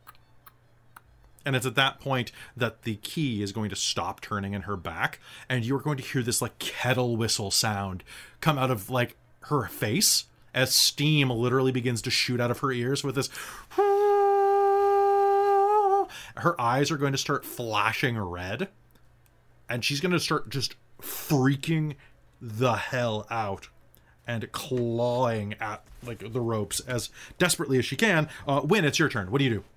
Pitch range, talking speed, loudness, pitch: 115-145 Hz, 165 wpm, -26 LUFS, 125 Hz